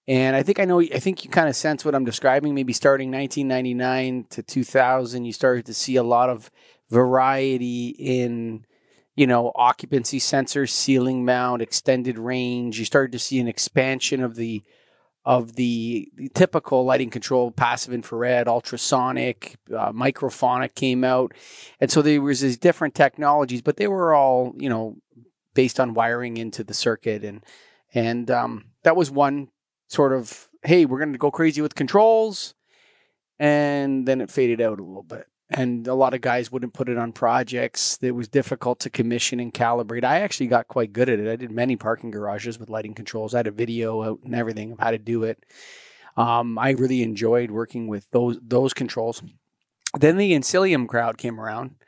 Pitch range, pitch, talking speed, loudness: 115-135 Hz, 125 Hz, 185 wpm, -22 LUFS